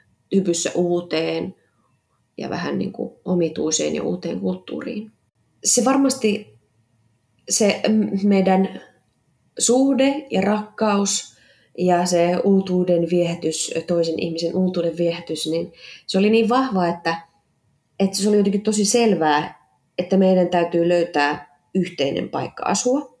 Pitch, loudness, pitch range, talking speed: 180 Hz, -20 LUFS, 165-210 Hz, 115 wpm